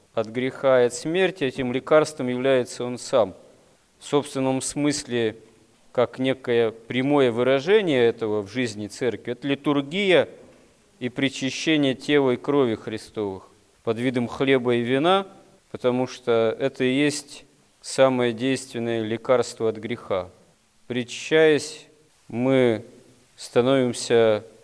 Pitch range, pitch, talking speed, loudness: 115-140 Hz, 130 Hz, 115 wpm, -23 LUFS